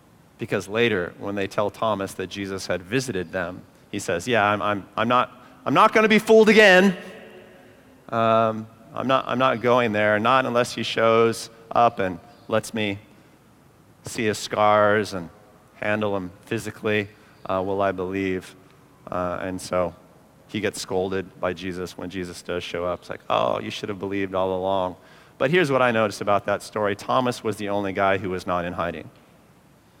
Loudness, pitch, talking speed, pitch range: -22 LUFS, 105 Hz, 180 wpm, 95-115 Hz